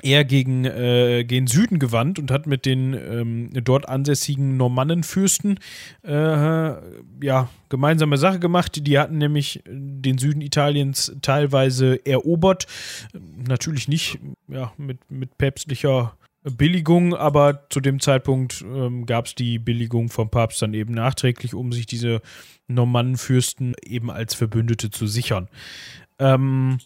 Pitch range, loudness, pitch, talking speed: 120-145 Hz, -21 LUFS, 130 Hz, 130 wpm